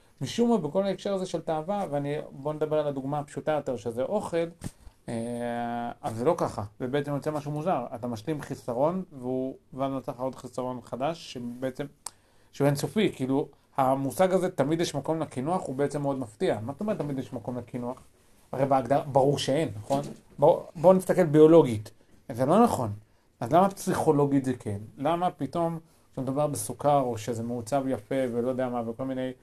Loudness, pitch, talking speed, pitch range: -28 LUFS, 140 Hz, 175 wpm, 125-155 Hz